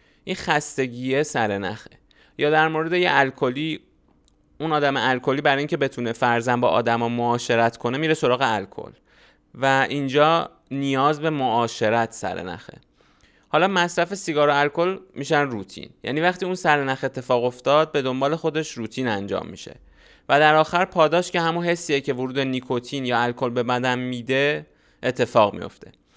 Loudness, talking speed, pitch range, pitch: -22 LUFS, 155 wpm, 120-155 Hz, 135 Hz